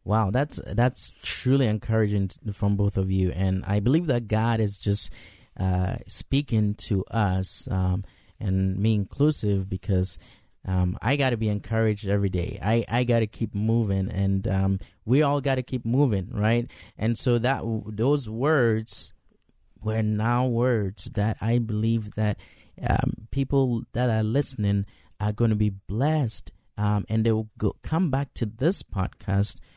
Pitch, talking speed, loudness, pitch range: 110 Hz, 165 wpm, -25 LUFS, 100-120 Hz